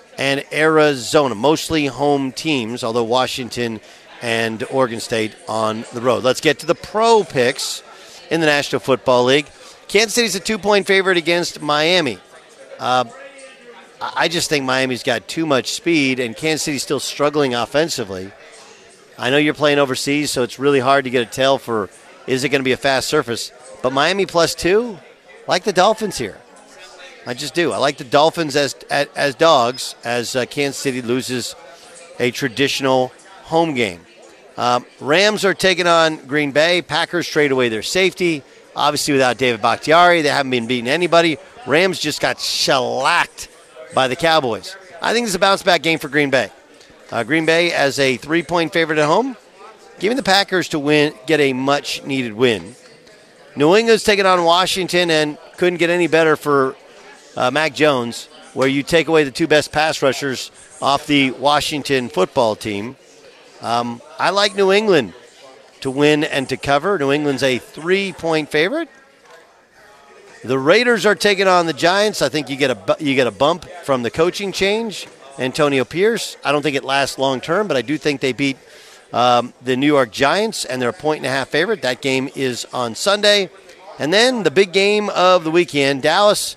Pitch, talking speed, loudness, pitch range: 150 Hz, 180 wpm, -17 LUFS, 130-170 Hz